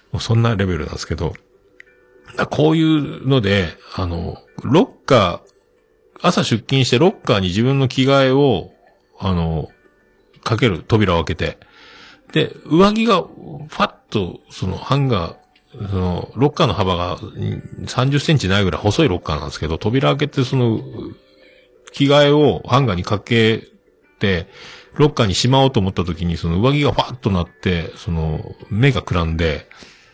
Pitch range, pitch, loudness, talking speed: 95-140 Hz, 120 Hz, -18 LUFS, 295 characters per minute